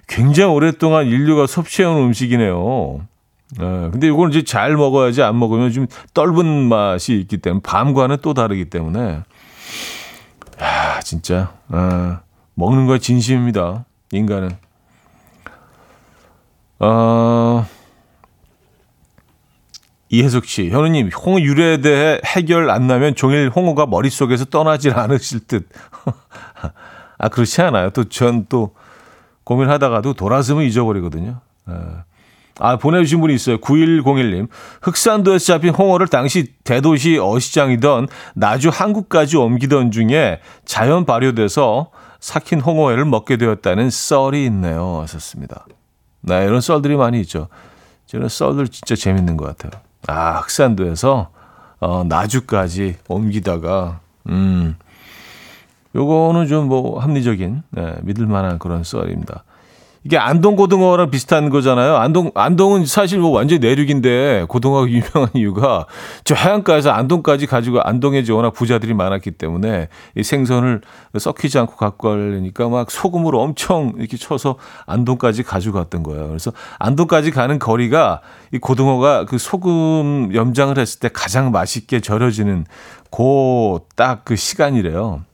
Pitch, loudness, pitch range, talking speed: 125 Hz, -15 LUFS, 105-145 Hz, 290 characters per minute